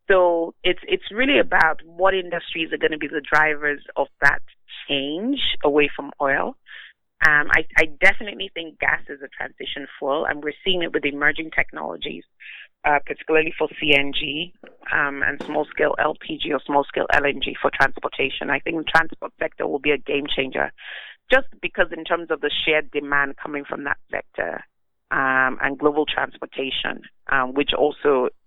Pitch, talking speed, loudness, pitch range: 155 Hz, 170 wpm, -21 LUFS, 145-180 Hz